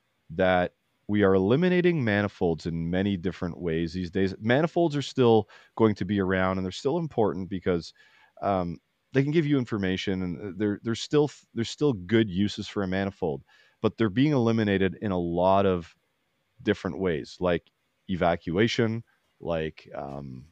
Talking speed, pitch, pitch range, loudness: 160 wpm, 100 Hz, 95-115 Hz, -27 LUFS